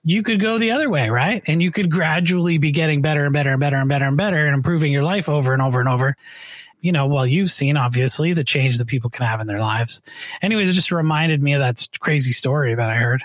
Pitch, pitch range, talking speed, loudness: 145 Hz, 130-170 Hz, 265 wpm, -18 LUFS